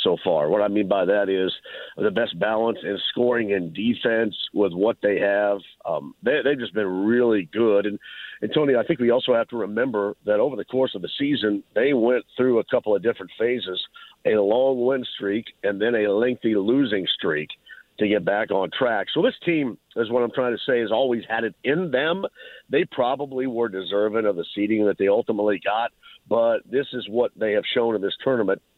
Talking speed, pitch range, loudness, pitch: 215 wpm, 105-130 Hz, -23 LUFS, 115 Hz